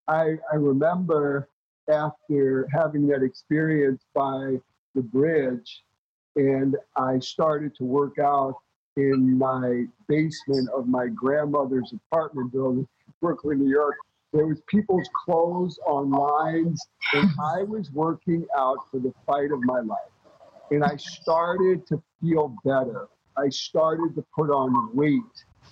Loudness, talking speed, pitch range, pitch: -25 LUFS, 135 wpm, 130-160 Hz, 145 Hz